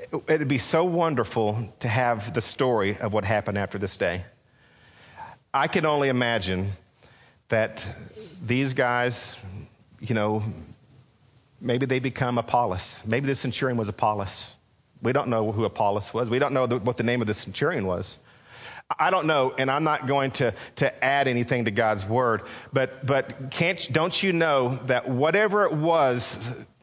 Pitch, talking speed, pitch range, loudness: 125 Hz, 165 wpm, 110-135 Hz, -24 LUFS